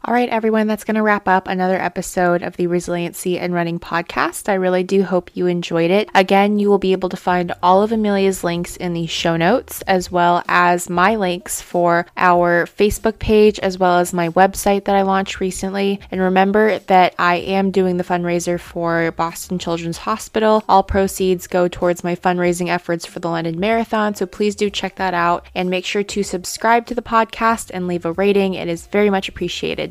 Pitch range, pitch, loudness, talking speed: 175-200 Hz, 185 Hz, -17 LUFS, 205 wpm